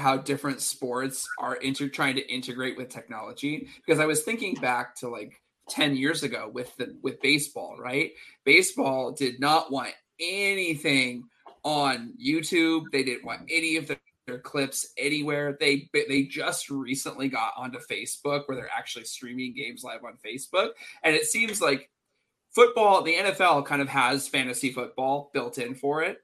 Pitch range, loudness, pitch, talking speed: 130-160 Hz, -26 LUFS, 140 Hz, 165 wpm